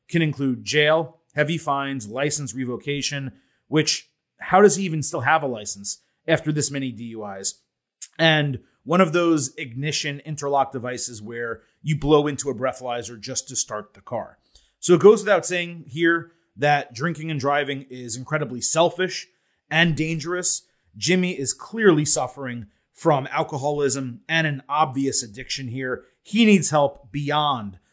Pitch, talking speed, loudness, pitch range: 145 Hz, 145 wpm, -22 LUFS, 130-160 Hz